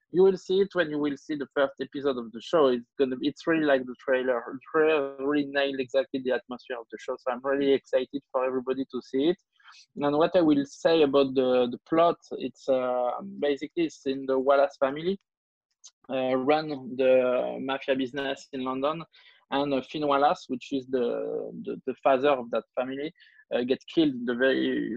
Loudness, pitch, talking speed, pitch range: -27 LUFS, 140 Hz, 190 wpm, 130-155 Hz